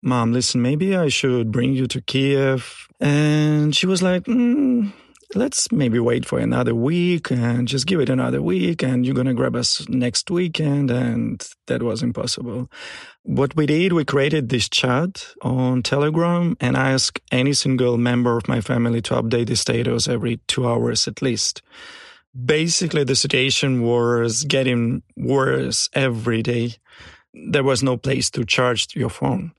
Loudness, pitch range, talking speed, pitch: -20 LUFS, 120-150 Hz, 160 wpm, 130 Hz